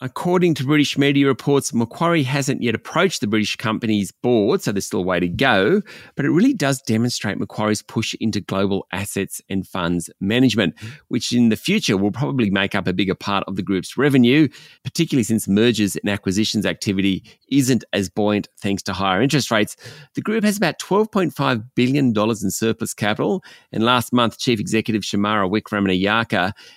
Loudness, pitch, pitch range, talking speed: -20 LUFS, 115 Hz, 100-140 Hz, 175 wpm